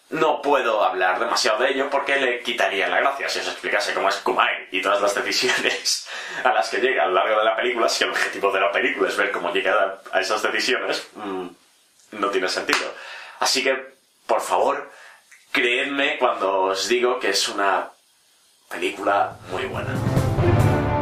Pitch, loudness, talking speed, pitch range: 125 Hz, -21 LUFS, 175 wpm, 100-130 Hz